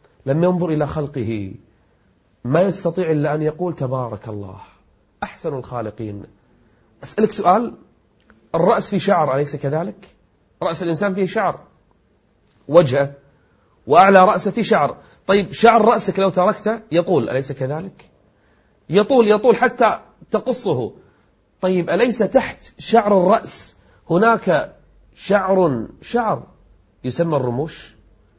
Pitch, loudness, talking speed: 160 Hz, -18 LUFS, 105 wpm